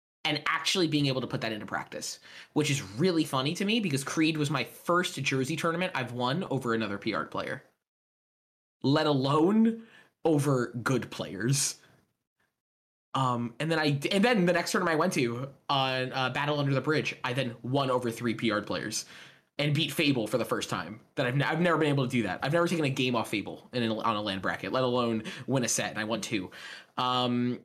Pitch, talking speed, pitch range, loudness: 135 Hz, 215 wpm, 120-155 Hz, -29 LUFS